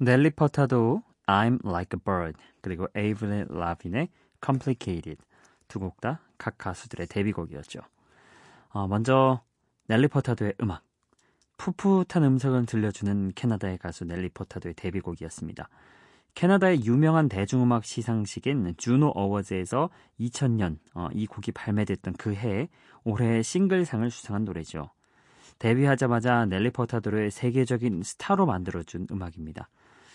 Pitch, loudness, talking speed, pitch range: 110 Hz, -27 LUFS, 330 characters per minute, 95-130 Hz